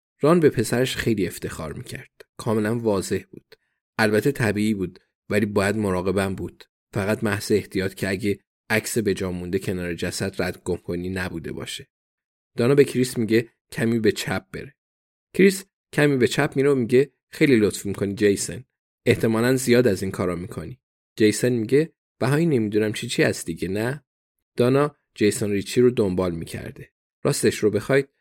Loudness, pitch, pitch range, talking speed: -23 LUFS, 110 Hz, 95-125 Hz, 155 wpm